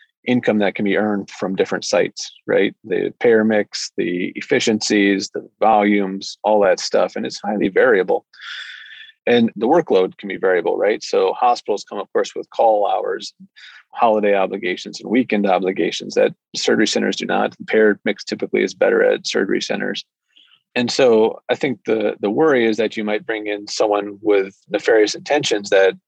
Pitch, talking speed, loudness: 145 Hz, 175 wpm, -18 LUFS